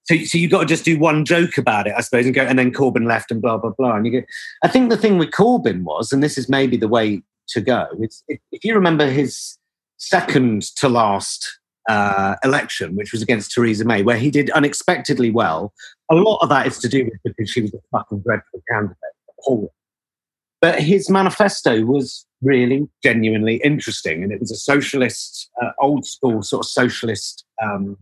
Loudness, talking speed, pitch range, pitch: -18 LUFS, 205 wpm, 115-150 Hz, 130 Hz